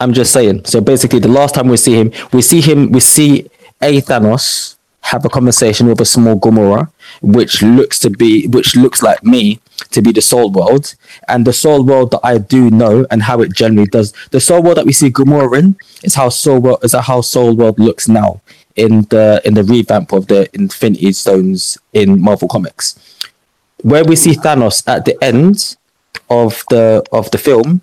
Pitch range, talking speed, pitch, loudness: 110-145 Hz, 200 wpm, 125 Hz, -9 LUFS